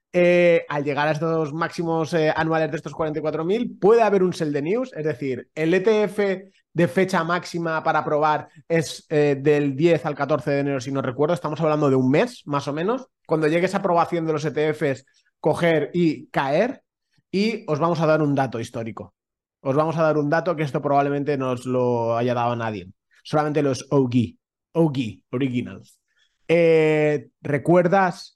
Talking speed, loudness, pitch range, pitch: 180 wpm, -22 LUFS, 140-170 Hz, 155 Hz